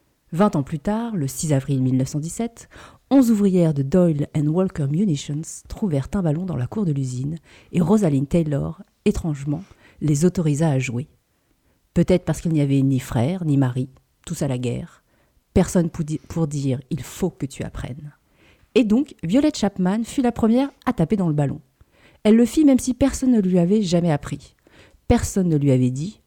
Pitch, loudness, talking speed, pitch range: 165 Hz, -21 LUFS, 185 wpm, 140-205 Hz